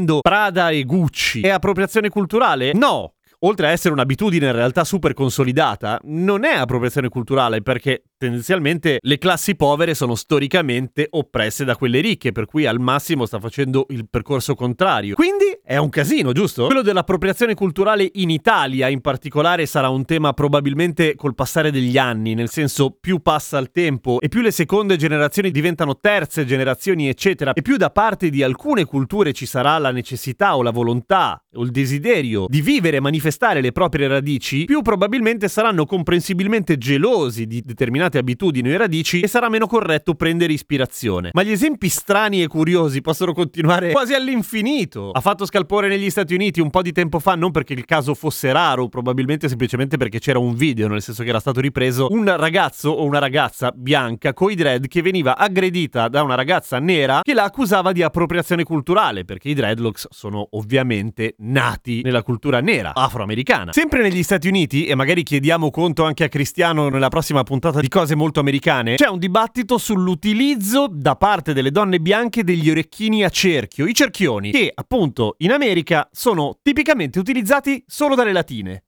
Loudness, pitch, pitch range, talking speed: -18 LUFS, 155 Hz, 130-190 Hz, 170 wpm